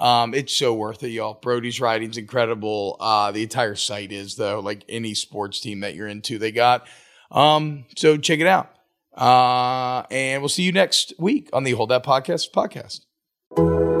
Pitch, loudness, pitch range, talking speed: 120 Hz, -21 LUFS, 105-130 Hz, 180 wpm